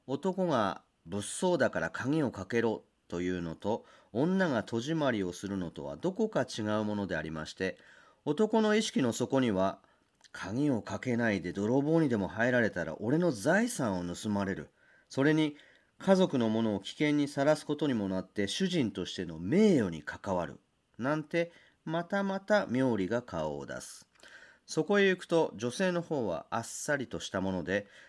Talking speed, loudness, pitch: 310 characters per minute, -32 LUFS, 125 Hz